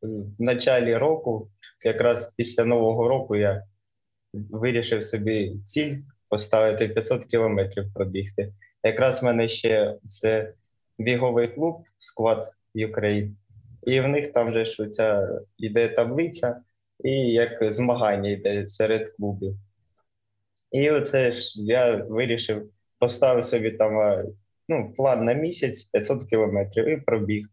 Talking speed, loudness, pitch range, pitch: 115 wpm, -24 LUFS, 105-120 Hz, 110 Hz